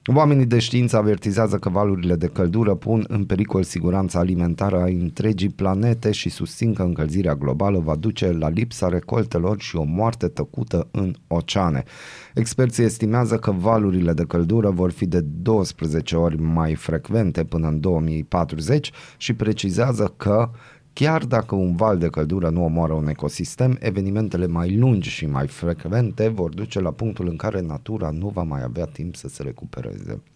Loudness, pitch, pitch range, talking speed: -22 LUFS, 95 Hz, 85-110 Hz, 160 wpm